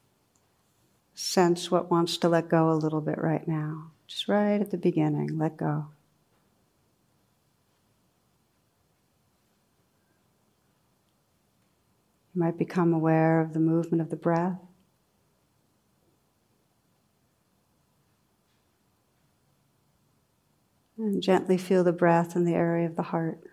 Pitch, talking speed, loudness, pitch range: 170 Hz, 100 wpm, -26 LUFS, 160-180 Hz